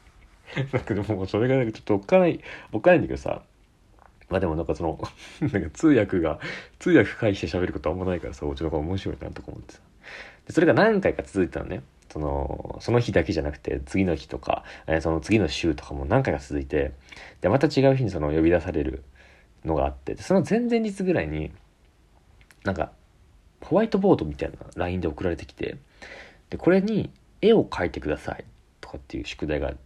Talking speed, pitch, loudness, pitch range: 400 characters per minute, 90 Hz, -25 LUFS, 75-125 Hz